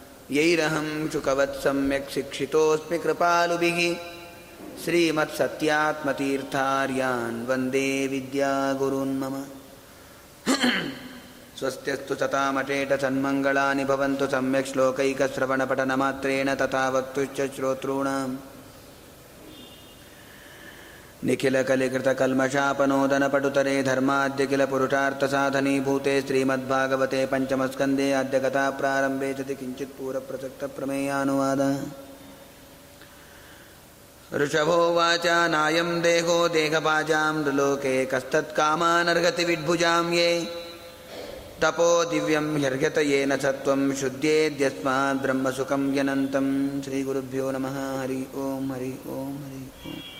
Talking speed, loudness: 60 wpm, -24 LUFS